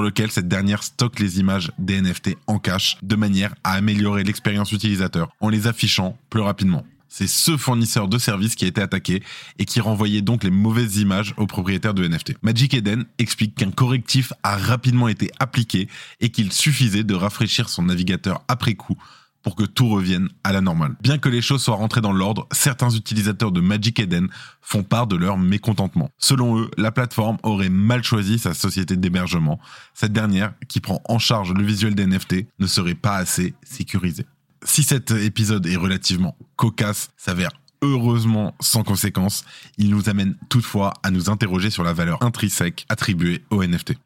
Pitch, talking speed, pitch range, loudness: 105 Hz, 180 wpm, 95-115 Hz, -20 LUFS